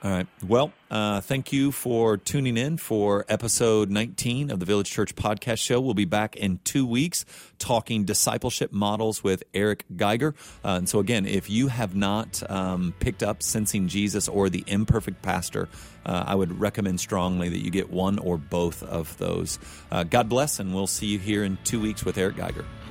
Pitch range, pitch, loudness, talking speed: 95-115 Hz, 105 Hz, -26 LUFS, 195 wpm